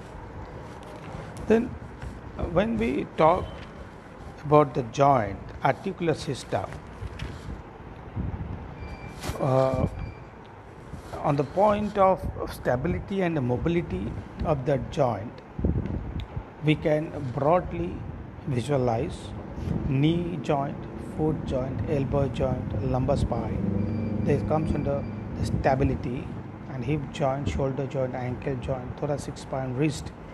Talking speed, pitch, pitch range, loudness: 95 wpm, 130 Hz, 110-150 Hz, -27 LUFS